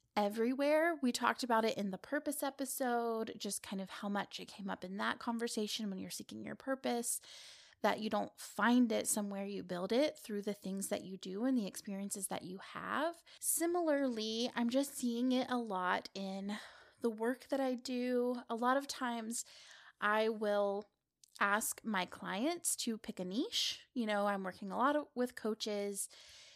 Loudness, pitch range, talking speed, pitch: -37 LUFS, 205-255 Hz, 180 wpm, 230 Hz